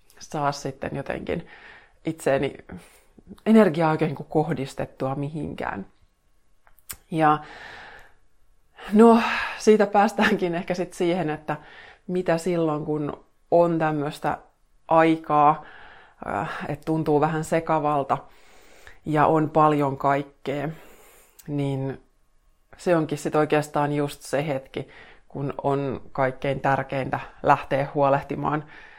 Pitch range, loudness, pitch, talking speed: 140-160 Hz, -24 LUFS, 150 Hz, 95 wpm